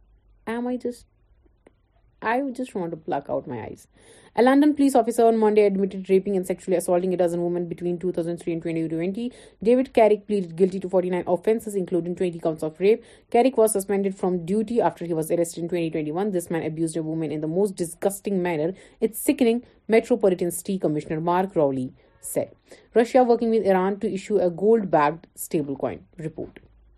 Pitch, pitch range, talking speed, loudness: 185 Hz, 170-220 Hz, 150 wpm, -23 LUFS